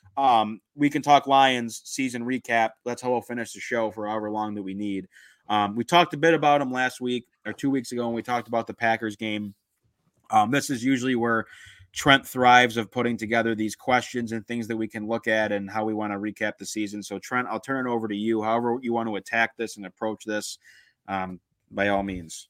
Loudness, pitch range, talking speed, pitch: -25 LUFS, 105-125 Hz, 230 wpm, 115 Hz